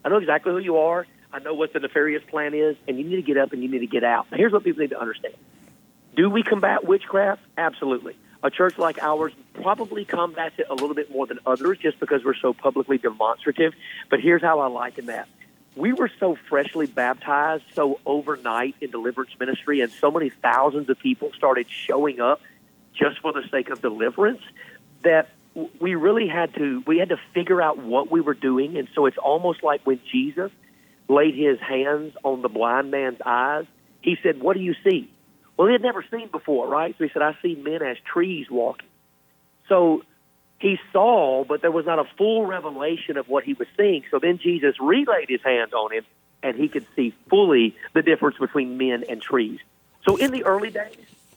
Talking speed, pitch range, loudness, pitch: 205 wpm, 140-195 Hz, -22 LUFS, 160 Hz